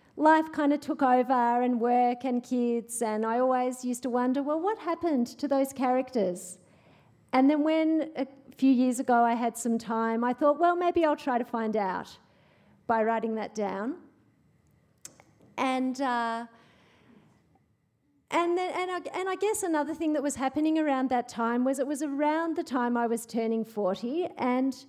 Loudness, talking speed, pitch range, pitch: -28 LUFS, 175 wpm, 235-300 Hz, 255 Hz